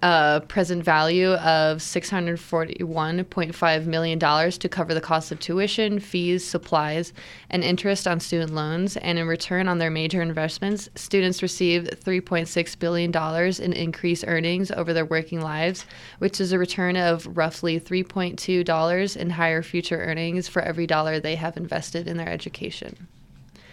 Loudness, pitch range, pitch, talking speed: -24 LUFS, 165-180 Hz, 170 Hz, 145 wpm